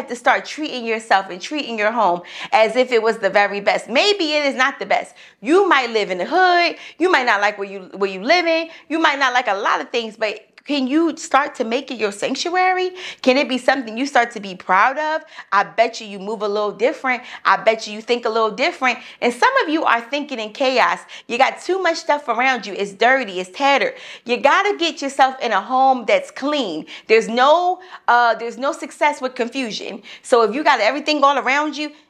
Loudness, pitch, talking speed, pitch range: -18 LUFS, 260 Hz, 230 wpm, 220-300 Hz